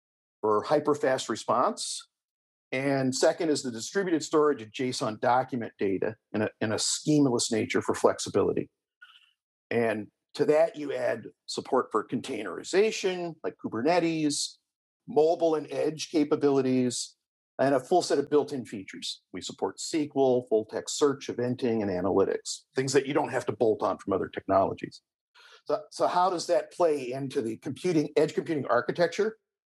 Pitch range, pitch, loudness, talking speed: 125-175 Hz, 150 Hz, -28 LUFS, 150 wpm